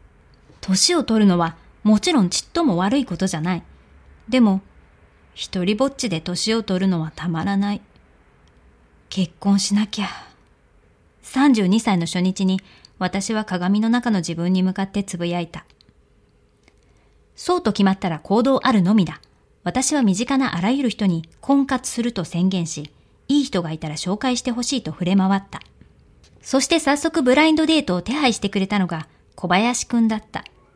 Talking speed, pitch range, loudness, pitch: 295 characters per minute, 180-245 Hz, -20 LUFS, 200 Hz